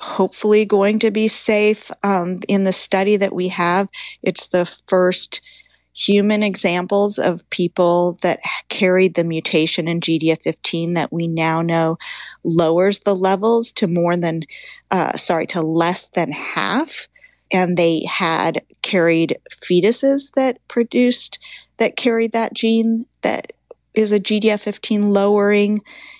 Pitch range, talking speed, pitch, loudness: 175-220 Hz, 130 wpm, 195 Hz, -18 LUFS